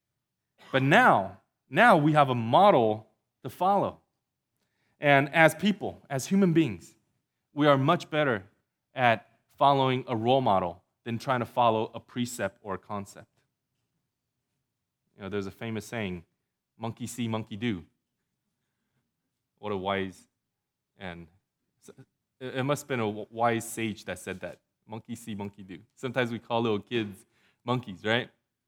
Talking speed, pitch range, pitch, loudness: 140 wpm, 105-130 Hz, 115 Hz, -27 LUFS